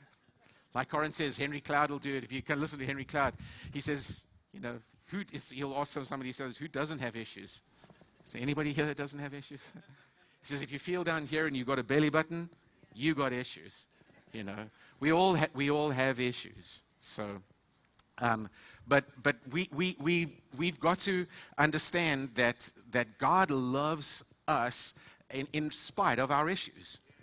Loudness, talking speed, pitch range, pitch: -33 LUFS, 185 wpm, 125-155 Hz, 140 Hz